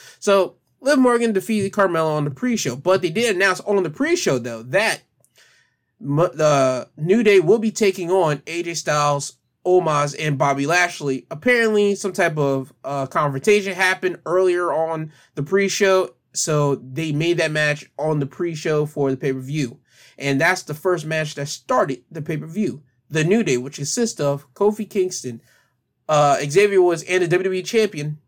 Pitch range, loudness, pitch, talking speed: 145-190 Hz, -20 LUFS, 160 Hz, 165 wpm